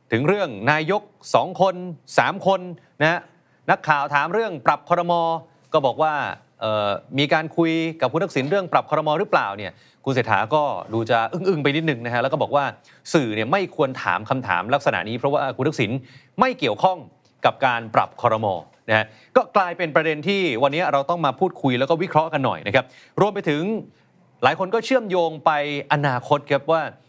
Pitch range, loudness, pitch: 130-180 Hz, -21 LUFS, 155 Hz